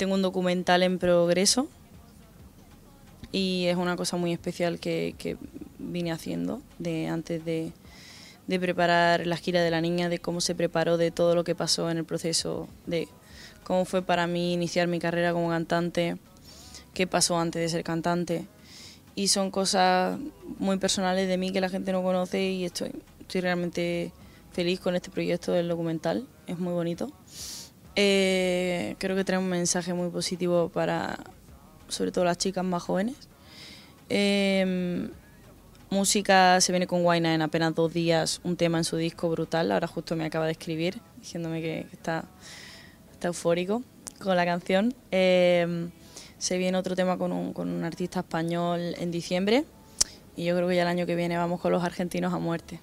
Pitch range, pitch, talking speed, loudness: 170-185 Hz, 175 Hz, 175 wpm, -27 LUFS